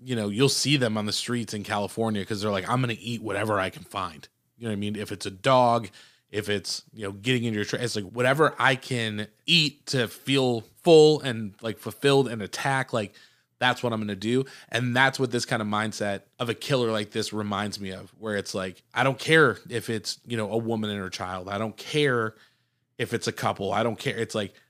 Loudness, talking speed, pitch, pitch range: -26 LUFS, 245 wpm, 115 Hz, 105-125 Hz